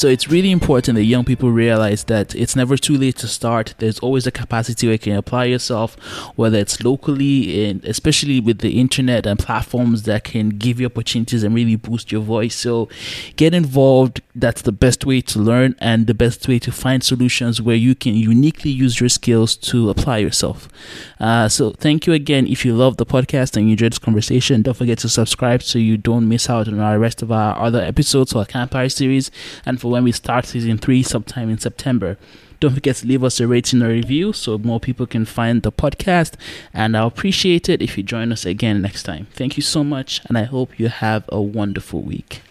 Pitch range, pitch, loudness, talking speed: 110-130 Hz, 120 Hz, -17 LUFS, 215 wpm